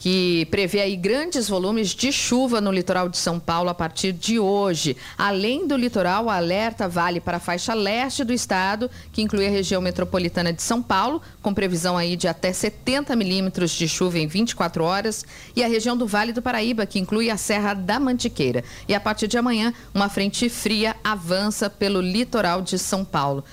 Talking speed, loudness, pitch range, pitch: 190 wpm, -22 LUFS, 180-225 Hz, 200 Hz